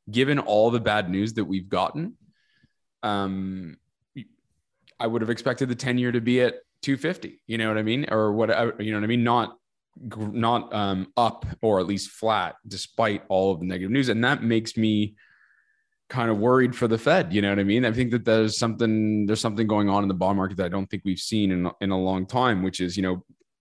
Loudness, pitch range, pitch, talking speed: -24 LUFS, 100-120 Hz, 110 Hz, 225 wpm